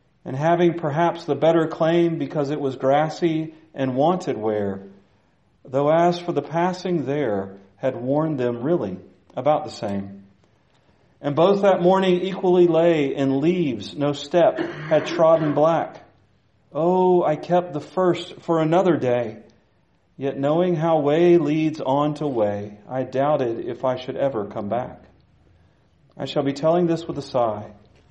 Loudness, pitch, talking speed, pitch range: -21 LUFS, 150 Hz, 150 wpm, 130-170 Hz